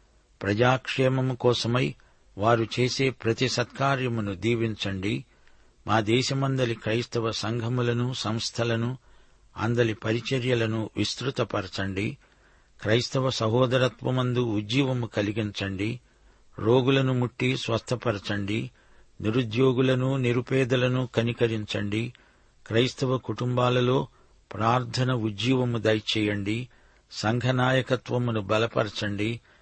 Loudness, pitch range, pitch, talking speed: -26 LUFS, 110-130 Hz, 120 Hz, 65 wpm